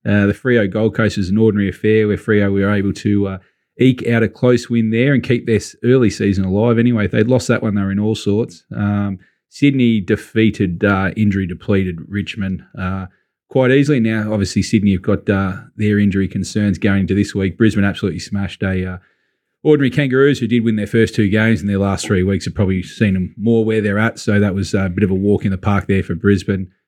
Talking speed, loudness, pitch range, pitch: 225 wpm, -16 LUFS, 100-110 Hz, 105 Hz